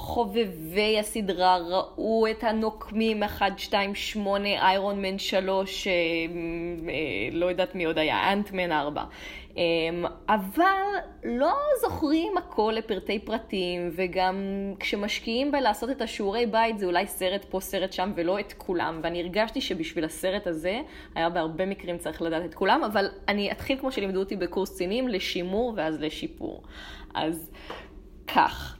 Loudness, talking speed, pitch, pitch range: -27 LUFS, 140 wpm, 195 Hz, 175-220 Hz